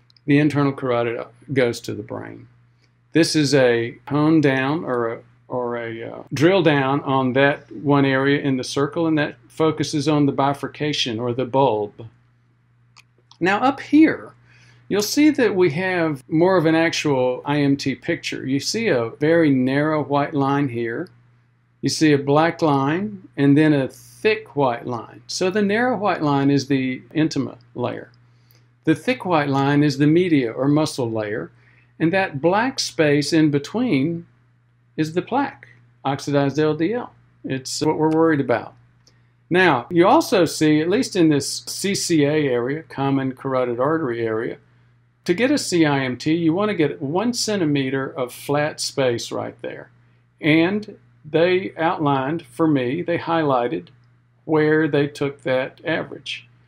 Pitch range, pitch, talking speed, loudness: 125-160 Hz, 140 Hz, 150 wpm, -20 LUFS